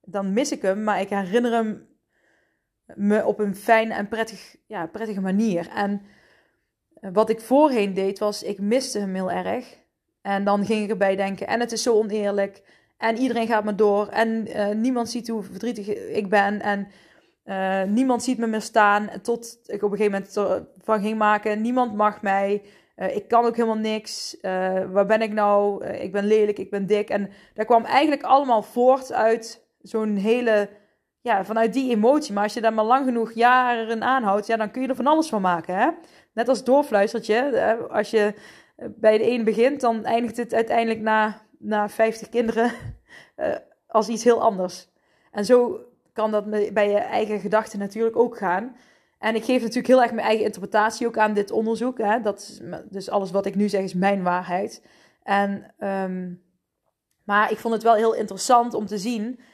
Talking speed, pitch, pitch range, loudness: 195 wpm, 215 Hz, 205-235 Hz, -22 LUFS